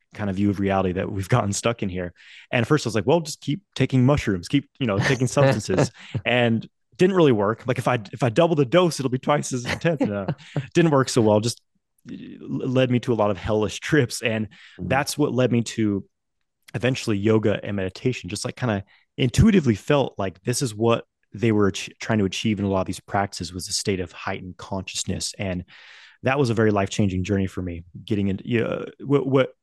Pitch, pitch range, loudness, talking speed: 115 Hz, 100-130 Hz, -23 LUFS, 225 wpm